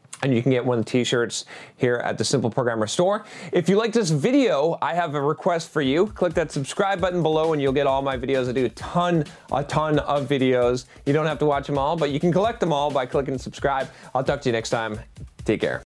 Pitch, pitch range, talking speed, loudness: 145 Hz, 130-175 Hz, 260 wpm, -23 LUFS